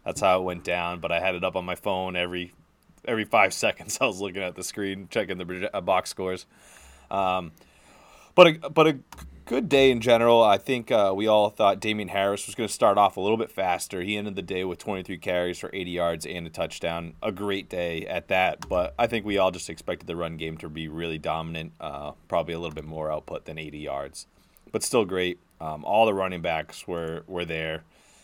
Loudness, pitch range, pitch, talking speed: -26 LUFS, 85-100 Hz, 90 Hz, 225 wpm